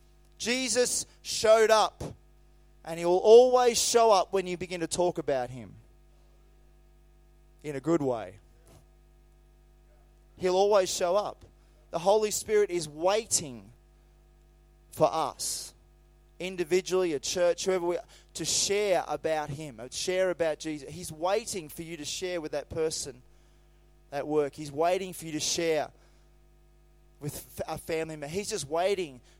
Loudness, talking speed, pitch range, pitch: -28 LUFS, 140 wpm, 155-190 Hz, 170 Hz